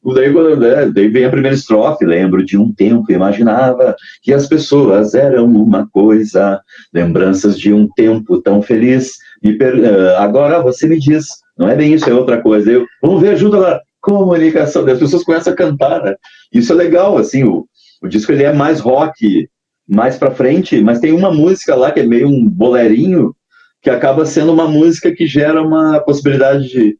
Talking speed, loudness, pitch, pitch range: 180 wpm, -10 LUFS, 140 Hz, 115-165 Hz